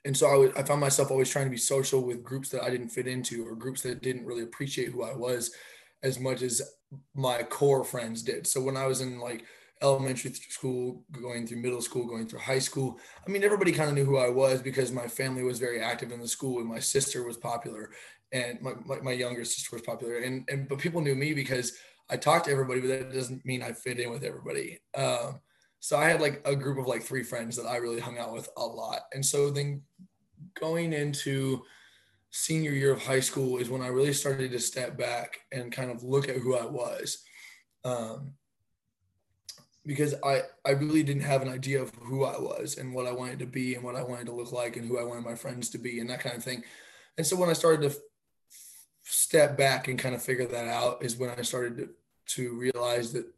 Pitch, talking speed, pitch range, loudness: 130 Hz, 235 wpm, 120-140 Hz, -30 LUFS